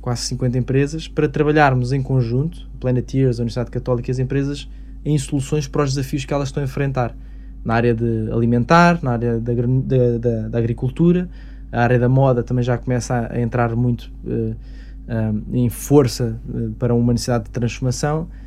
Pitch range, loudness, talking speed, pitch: 120-140 Hz, -19 LUFS, 175 wpm, 125 Hz